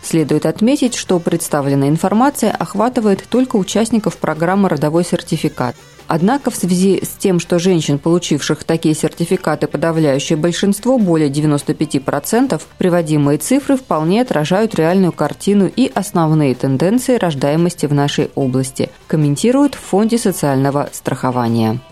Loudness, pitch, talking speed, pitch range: -15 LUFS, 170 Hz, 120 wpm, 150-200 Hz